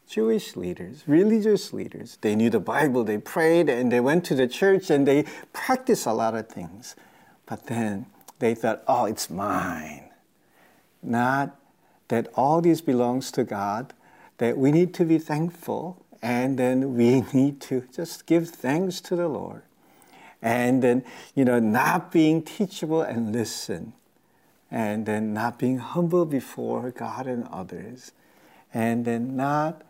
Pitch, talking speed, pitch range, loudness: 130 Hz, 150 wpm, 115-165 Hz, -24 LUFS